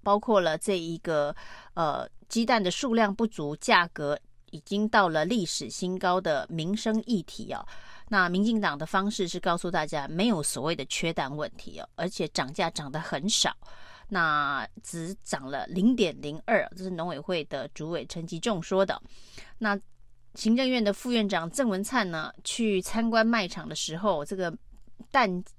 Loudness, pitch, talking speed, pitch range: -28 LUFS, 190 Hz, 245 characters per minute, 160-220 Hz